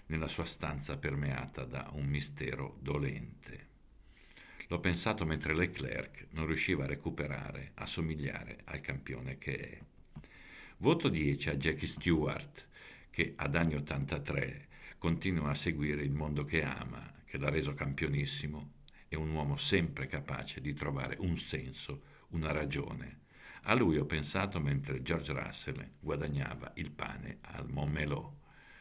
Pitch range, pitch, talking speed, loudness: 70-80 Hz, 75 Hz, 135 wpm, -37 LUFS